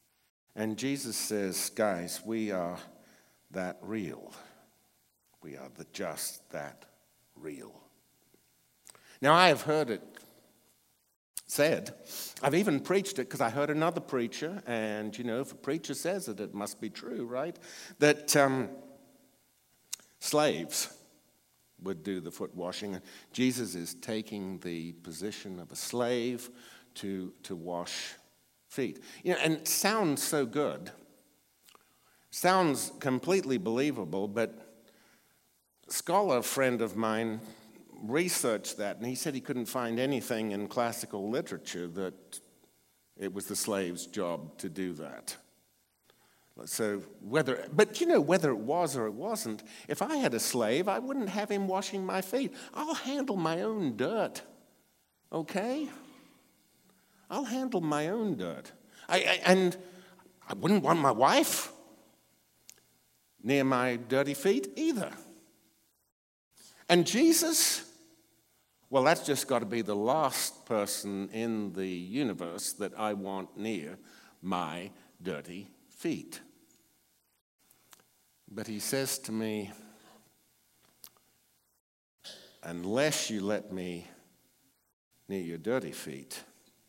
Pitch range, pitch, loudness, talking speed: 100-160 Hz, 115 Hz, -31 LUFS, 125 wpm